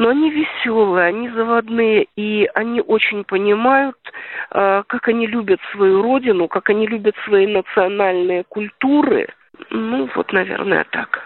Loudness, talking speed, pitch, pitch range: -17 LUFS, 130 wpm, 220 Hz, 195-240 Hz